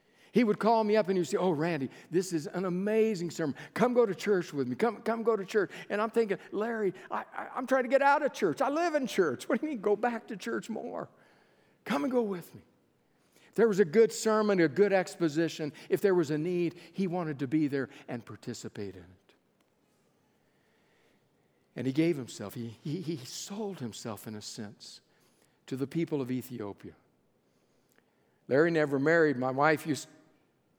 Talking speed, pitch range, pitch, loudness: 205 wpm, 145-215 Hz, 175 Hz, -30 LUFS